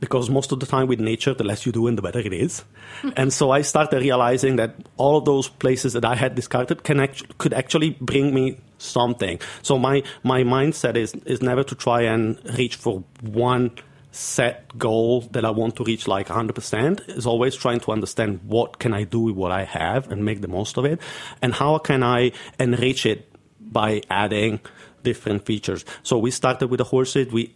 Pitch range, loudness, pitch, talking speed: 115-135 Hz, -22 LUFS, 125 Hz, 210 wpm